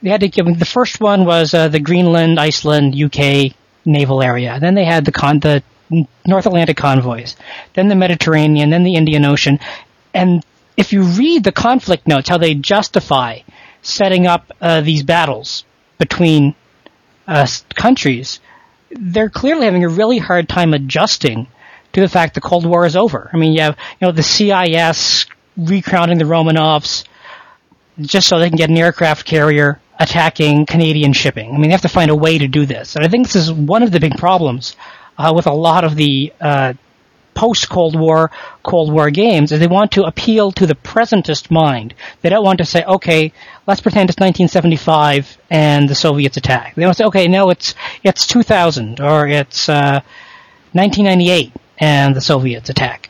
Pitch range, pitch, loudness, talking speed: 150-185 Hz, 165 Hz, -12 LUFS, 180 wpm